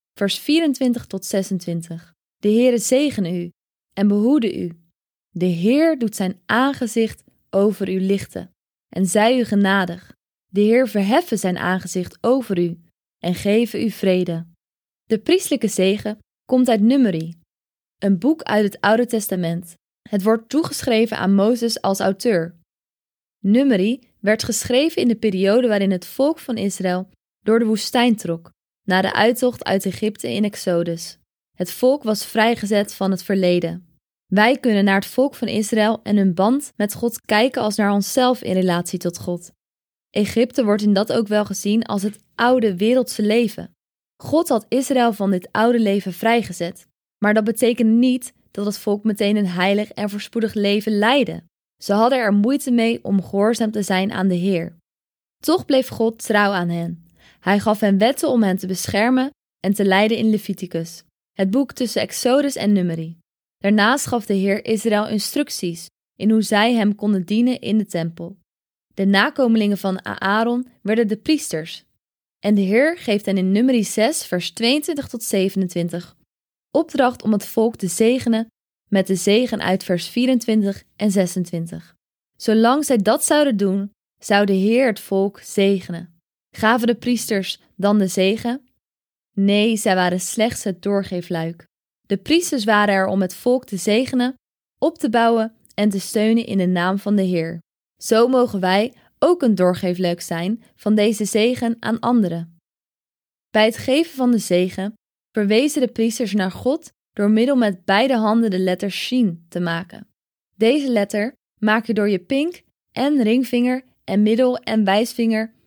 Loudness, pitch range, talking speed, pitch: -19 LUFS, 190-235 Hz, 160 wpm, 210 Hz